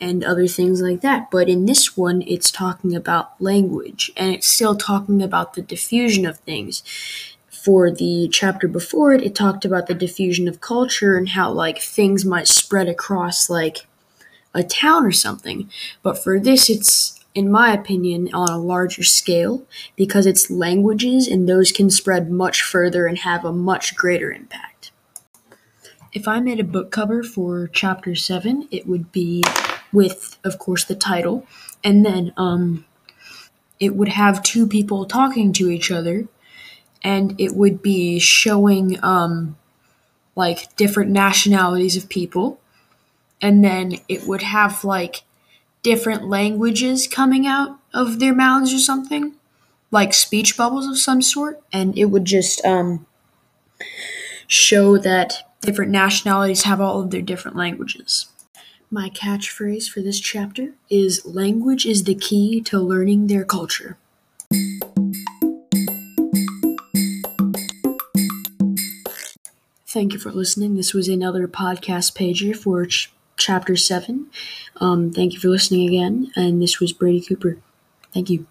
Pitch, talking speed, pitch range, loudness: 195 Hz, 145 wpm, 180-210 Hz, -18 LUFS